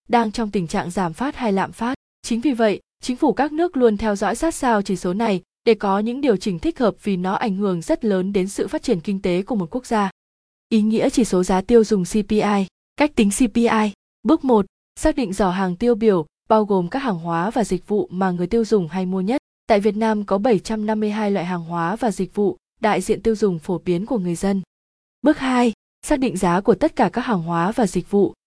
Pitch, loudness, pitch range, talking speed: 215 Hz, -20 LUFS, 190-240 Hz, 240 wpm